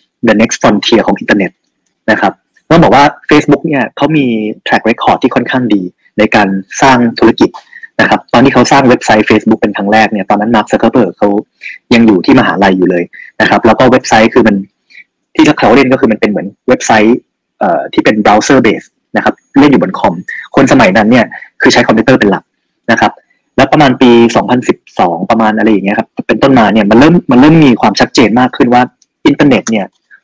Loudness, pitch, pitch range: -8 LUFS, 110 Hz, 105-125 Hz